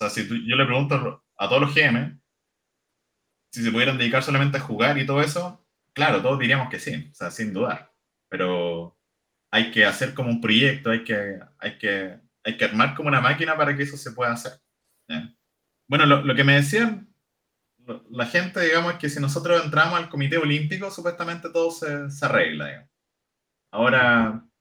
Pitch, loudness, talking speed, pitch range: 140 Hz, -22 LUFS, 195 wpm, 115-155 Hz